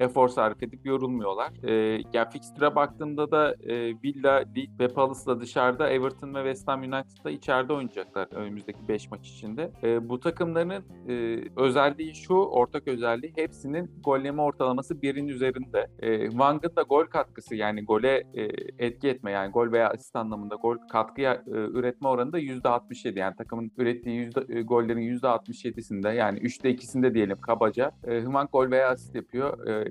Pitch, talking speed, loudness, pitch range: 125 Hz, 160 wpm, -28 LUFS, 115-135 Hz